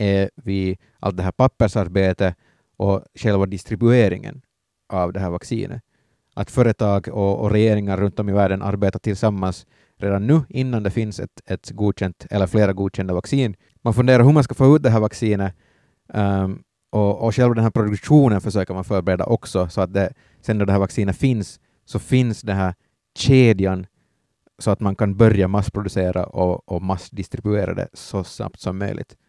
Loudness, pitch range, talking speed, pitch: -20 LUFS, 95-115 Hz, 175 wpm, 100 Hz